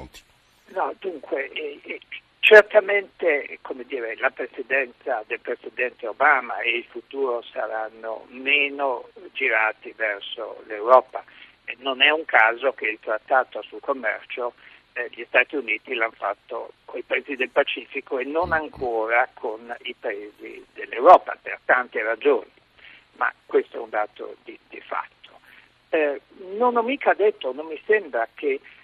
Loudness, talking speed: -22 LUFS, 135 wpm